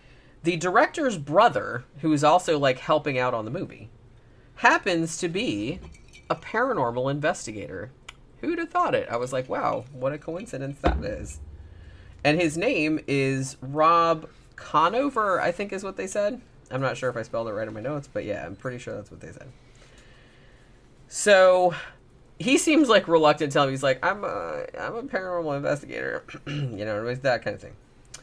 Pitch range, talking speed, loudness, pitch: 125-175 Hz, 185 wpm, -25 LUFS, 140 Hz